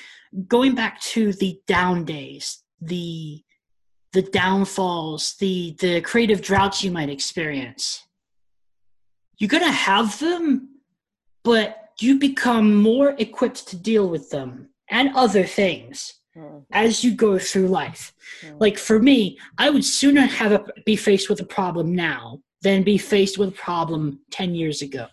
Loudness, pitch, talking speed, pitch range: -20 LUFS, 195 Hz, 145 wpm, 160-220 Hz